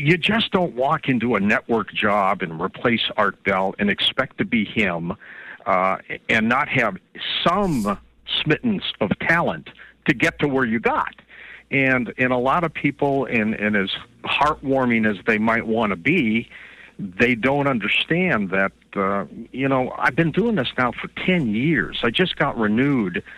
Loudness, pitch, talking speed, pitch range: -21 LUFS, 130 Hz, 170 wpm, 115-165 Hz